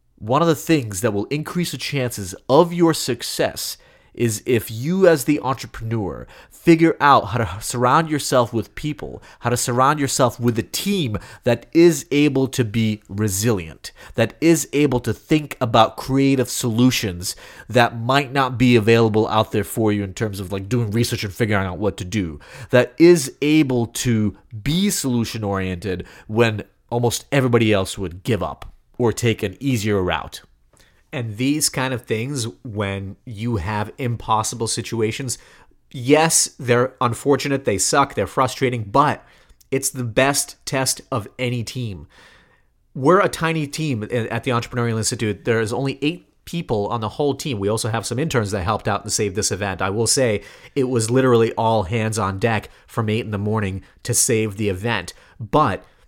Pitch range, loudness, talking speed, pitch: 105-135 Hz, -20 LUFS, 170 wpm, 120 Hz